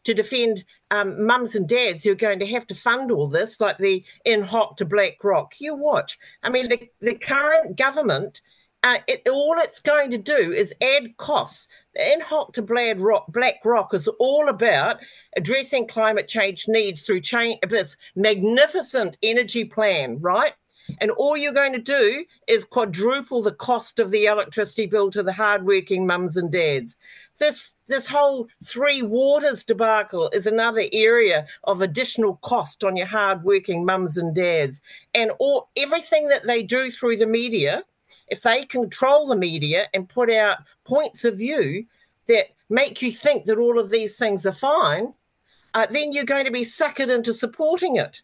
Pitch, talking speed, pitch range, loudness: 235 Hz, 170 wpm, 205-275 Hz, -21 LUFS